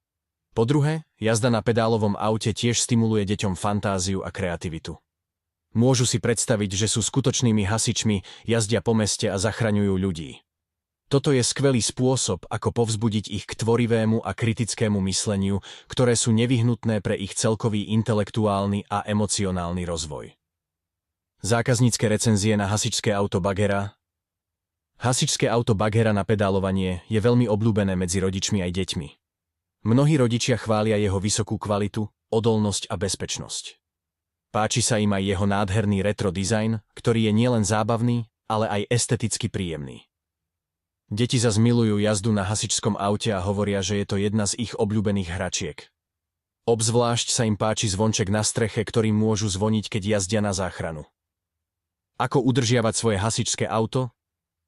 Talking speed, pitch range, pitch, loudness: 135 wpm, 95-115 Hz, 105 Hz, -23 LUFS